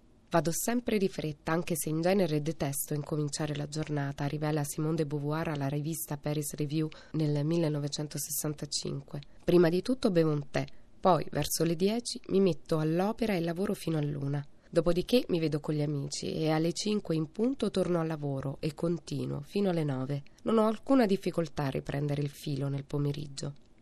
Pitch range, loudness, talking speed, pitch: 145-175 Hz, -31 LUFS, 170 wpm, 155 Hz